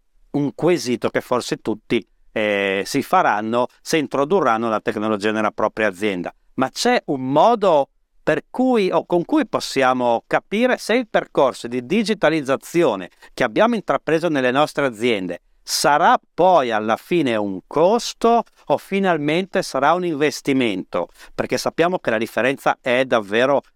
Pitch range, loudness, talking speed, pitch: 115-175 Hz, -19 LUFS, 140 wpm, 140 Hz